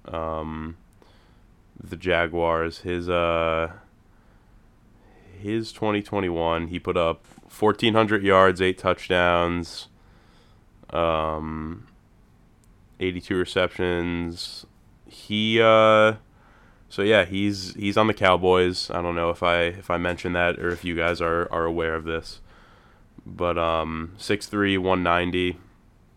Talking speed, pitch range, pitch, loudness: 115 wpm, 85-100 Hz, 90 Hz, -23 LUFS